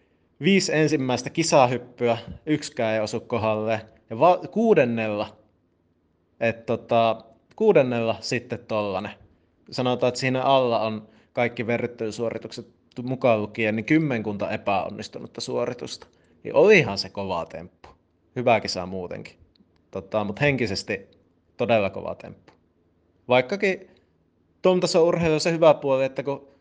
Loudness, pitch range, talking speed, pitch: -23 LUFS, 100-135 Hz, 115 wpm, 115 Hz